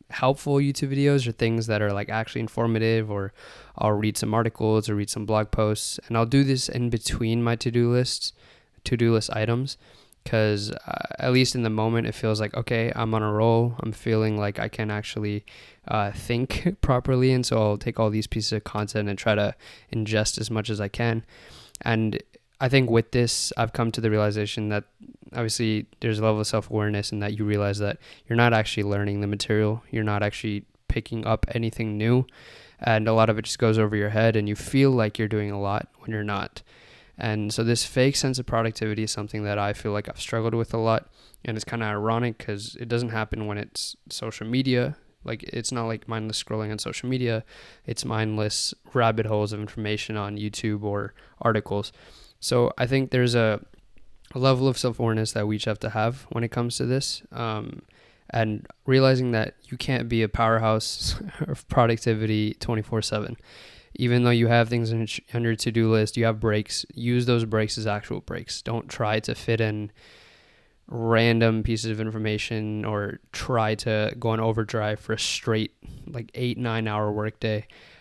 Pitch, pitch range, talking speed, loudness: 110 Hz, 105-120 Hz, 200 wpm, -25 LUFS